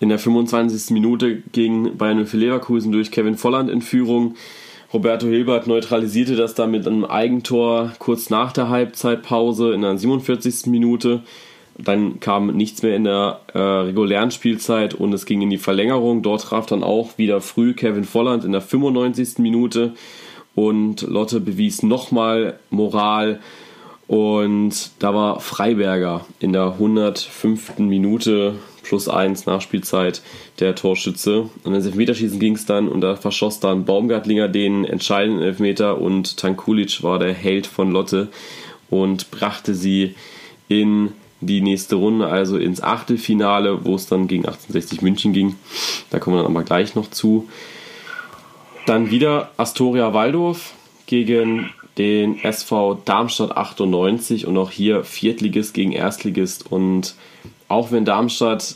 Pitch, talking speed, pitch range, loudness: 110 Hz, 140 wpm, 100-115 Hz, -19 LUFS